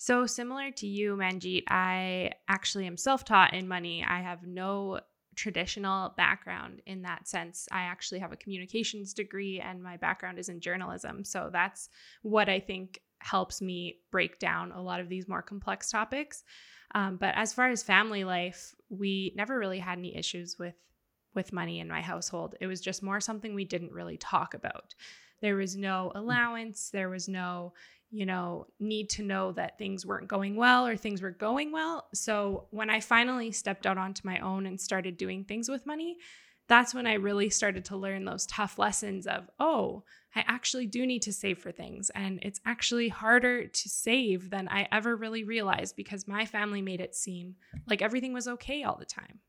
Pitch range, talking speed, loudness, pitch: 185-220 Hz, 190 wpm, -31 LUFS, 200 Hz